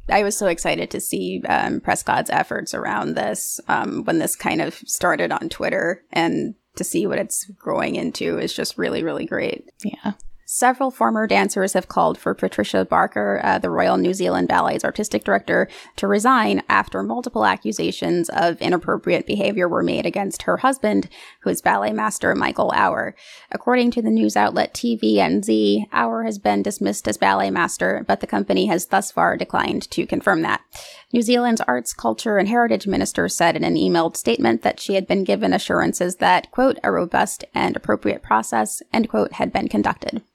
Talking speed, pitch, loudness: 180 wpm, 175 Hz, -20 LUFS